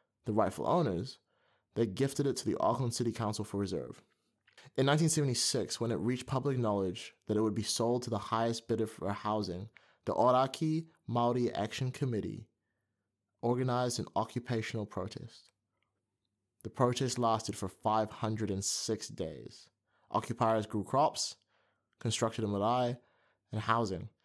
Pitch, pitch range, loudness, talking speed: 115 Hz, 105-125 Hz, -34 LUFS, 135 wpm